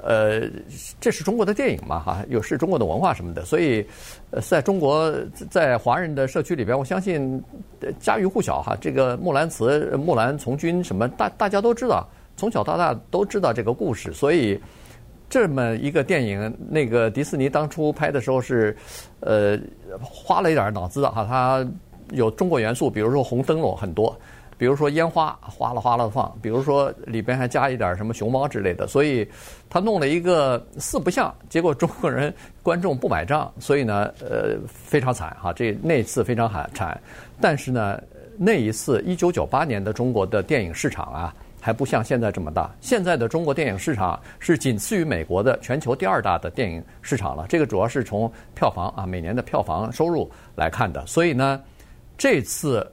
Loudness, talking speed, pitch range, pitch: -23 LUFS, 285 characters per minute, 110-150 Hz, 130 Hz